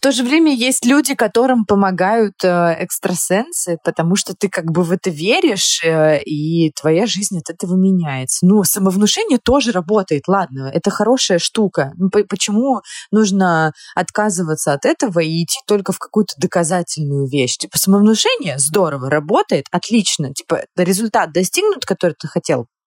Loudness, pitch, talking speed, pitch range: -16 LUFS, 190 Hz, 140 wpm, 165-215 Hz